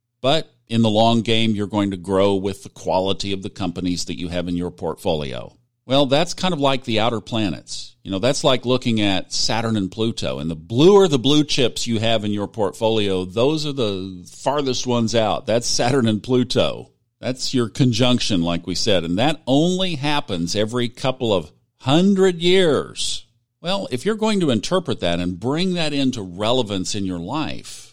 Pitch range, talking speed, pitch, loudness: 100-135 Hz, 195 wpm, 115 Hz, -20 LUFS